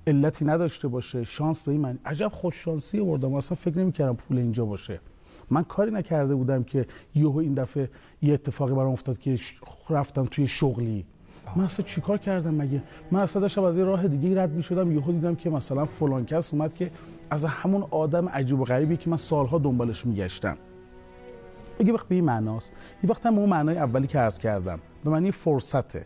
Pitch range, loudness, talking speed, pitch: 125-170 Hz, -26 LUFS, 185 wpm, 150 Hz